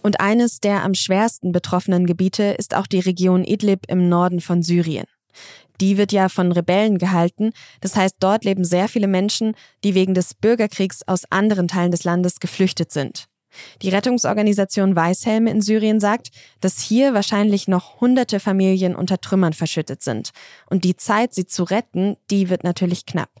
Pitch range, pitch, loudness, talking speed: 180-205 Hz, 190 Hz, -19 LUFS, 170 wpm